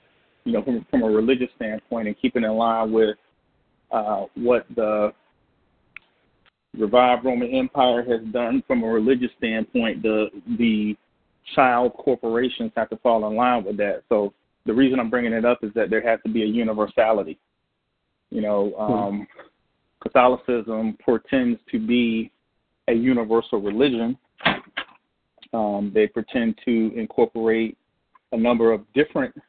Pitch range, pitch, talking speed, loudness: 110-125 Hz, 115 Hz, 140 wpm, -22 LUFS